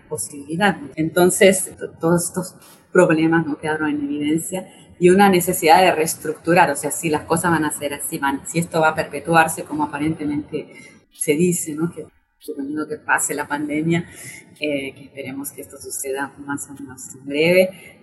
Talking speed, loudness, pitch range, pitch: 170 wpm, -19 LUFS, 145-170 Hz, 155 Hz